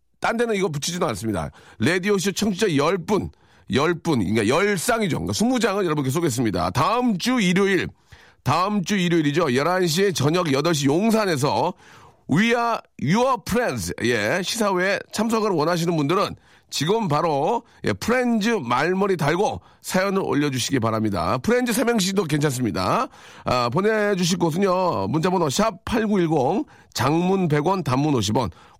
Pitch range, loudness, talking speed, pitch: 150-210 Hz, -21 LUFS, 320 characters per minute, 185 Hz